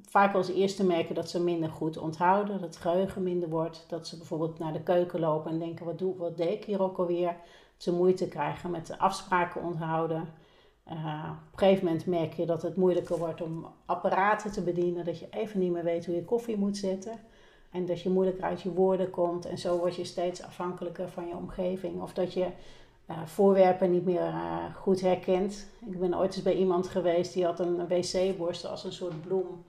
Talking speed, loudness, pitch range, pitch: 220 wpm, -30 LUFS, 170-185 Hz, 180 Hz